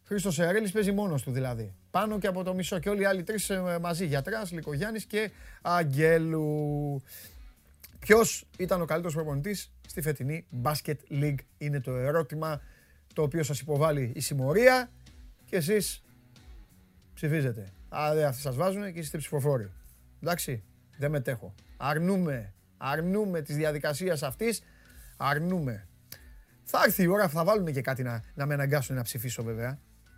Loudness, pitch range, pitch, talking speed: -29 LUFS, 125-175 Hz, 150 Hz, 145 wpm